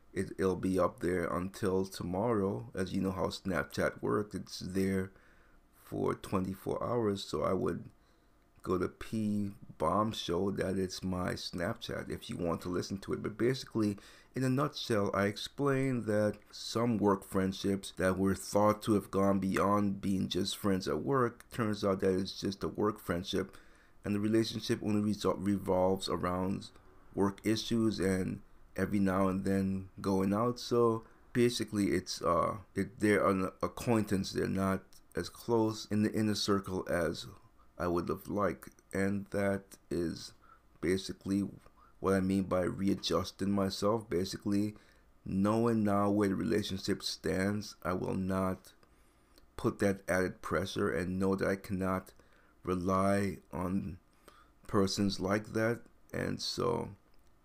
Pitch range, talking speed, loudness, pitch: 95-105 Hz, 145 wpm, -34 LUFS, 100 Hz